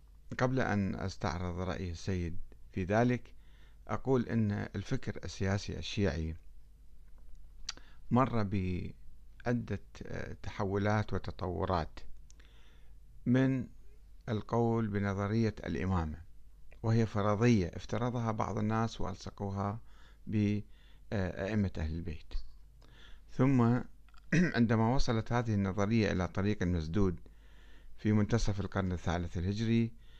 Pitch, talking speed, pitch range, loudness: 100 Hz, 85 wpm, 85-115 Hz, -34 LUFS